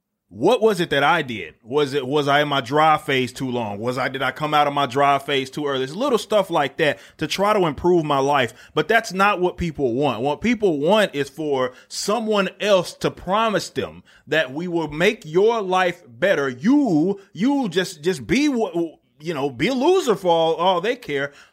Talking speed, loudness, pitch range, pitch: 215 wpm, -20 LUFS, 140-205 Hz, 165 Hz